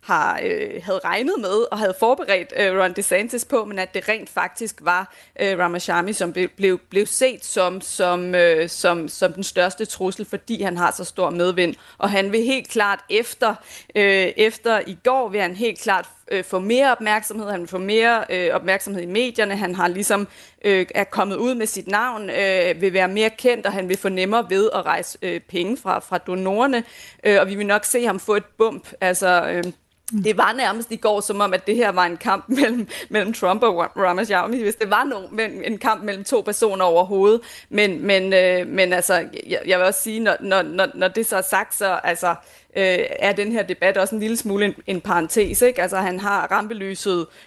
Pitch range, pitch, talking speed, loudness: 185-220 Hz, 200 Hz, 210 wpm, -20 LUFS